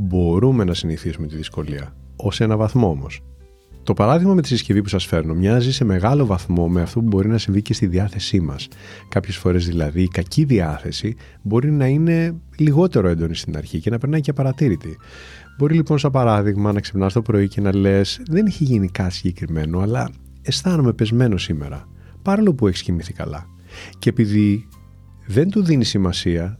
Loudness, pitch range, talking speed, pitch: -19 LUFS, 85-120 Hz, 180 wpm, 100 Hz